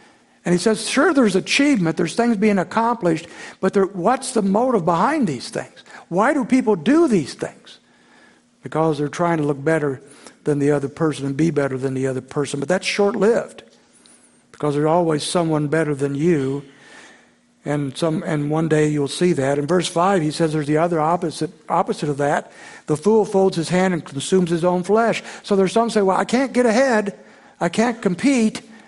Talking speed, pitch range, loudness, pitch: 195 wpm, 150-215 Hz, -19 LUFS, 175 Hz